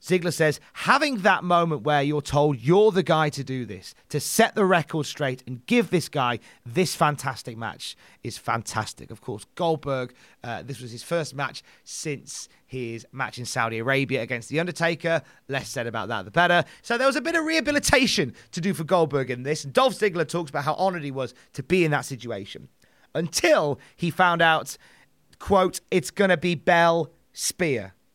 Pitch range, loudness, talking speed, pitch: 125-180 Hz, -24 LUFS, 190 wpm, 150 Hz